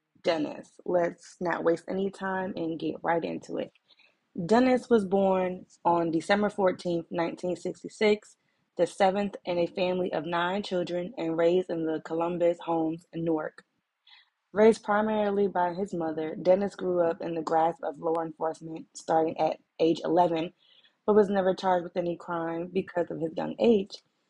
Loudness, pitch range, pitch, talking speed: -28 LUFS, 165-190 Hz, 175 Hz, 160 wpm